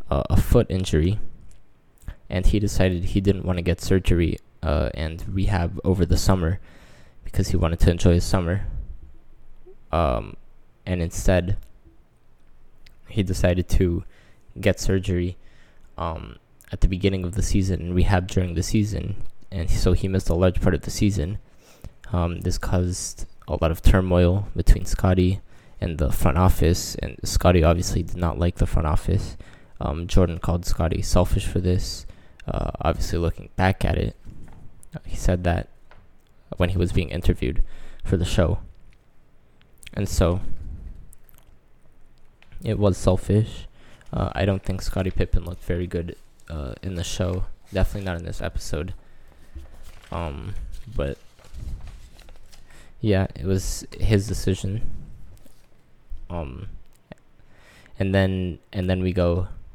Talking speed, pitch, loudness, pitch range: 140 wpm, 90 Hz, -24 LUFS, 85-95 Hz